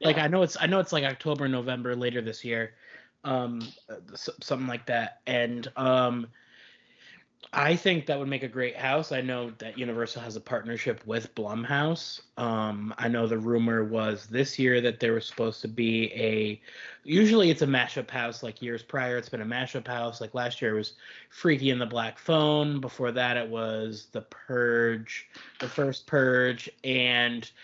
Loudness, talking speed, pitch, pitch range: -28 LUFS, 180 wpm, 125 Hz, 115-135 Hz